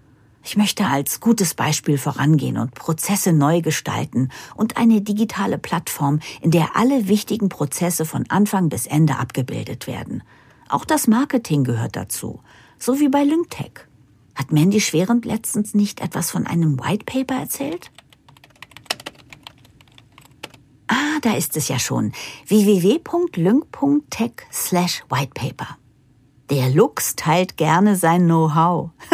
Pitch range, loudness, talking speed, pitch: 145-220 Hz, -19 LUFS, 125 wpm, 170 Hz